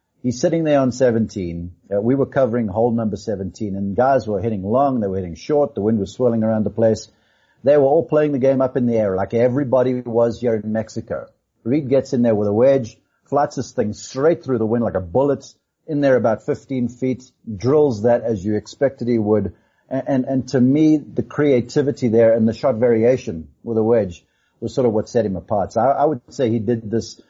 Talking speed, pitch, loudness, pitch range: 225 wpm, 120 Hz, -19 LUFS, 110-135 Hz